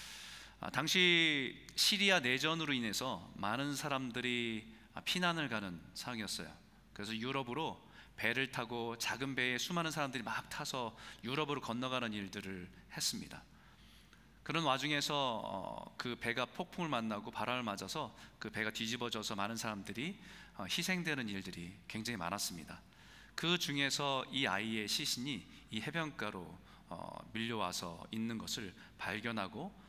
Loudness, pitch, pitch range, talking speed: -37 LUFS, 125 Hz, 110-150 Hz, 295 characters per minute